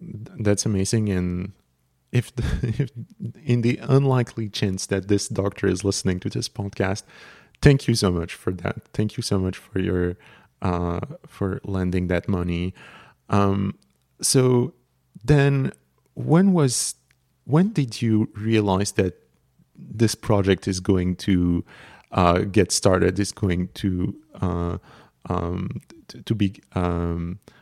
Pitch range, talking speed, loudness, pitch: 90-115 Hz, 135 wpm, -23 LUFS, 100 Hz